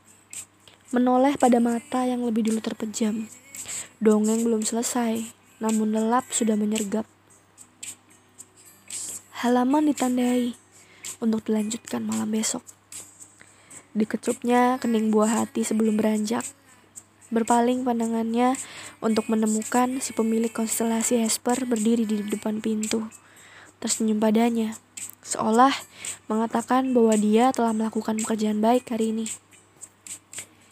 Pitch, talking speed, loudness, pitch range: 225 Hz, 100 wpm, -24 LUFS, 215-240 Hz